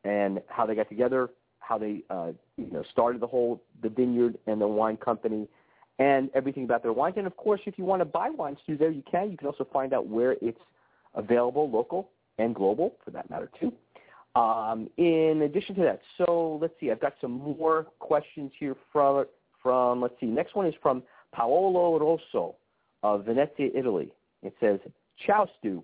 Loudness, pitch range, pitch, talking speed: -28 LUFS, 115-160 Hz, 135 Hz, 195 wpm